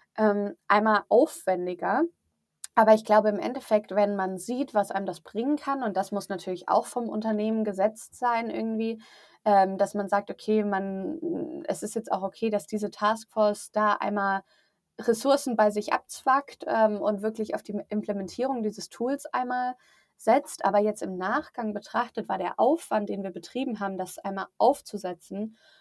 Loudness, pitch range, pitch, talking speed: -27 LUFS, 195-235 Hz, 210 Hz, 165 wpm